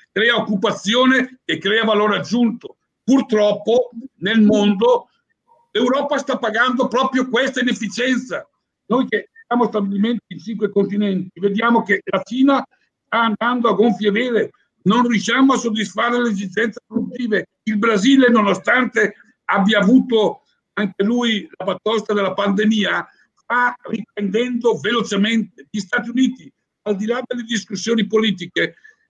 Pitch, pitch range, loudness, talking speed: 225 Hz, 205-245 Hz, -18 LUFS, 125 wpm